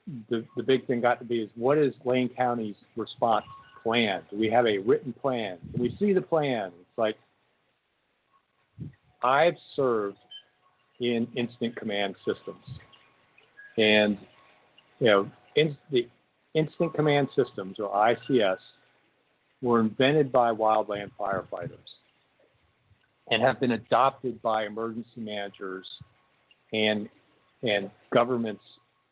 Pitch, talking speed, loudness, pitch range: 120 Hz, 120 wpm, -27 LUFS, 110-135 Hz